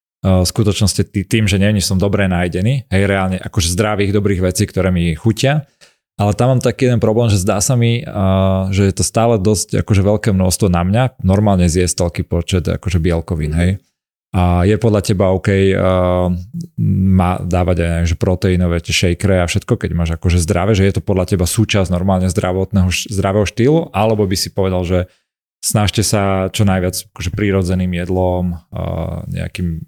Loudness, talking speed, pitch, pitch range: -15 LUFS, 175 wpm, 95 Hz, 90-105 Hz